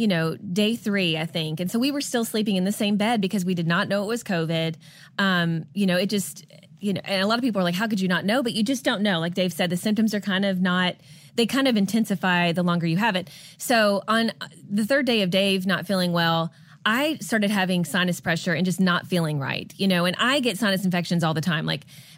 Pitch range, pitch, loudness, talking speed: 170-215 Hz, 190 Hz, -23 LUFS, 260 wpm